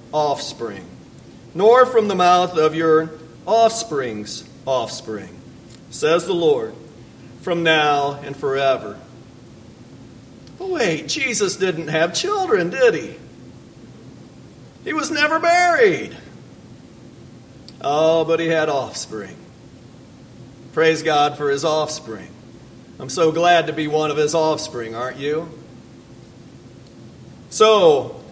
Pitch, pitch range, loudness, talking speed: 155 Hz, 135-205 Hz, -18 LUFS, 105 wpm